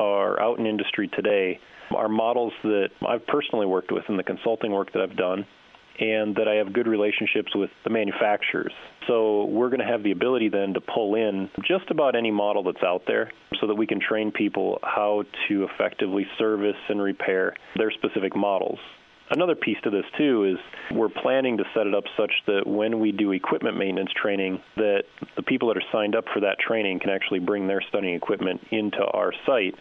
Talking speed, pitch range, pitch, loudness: 200 wpm, 100-110 Hz, 105 Hz, -25 LUFS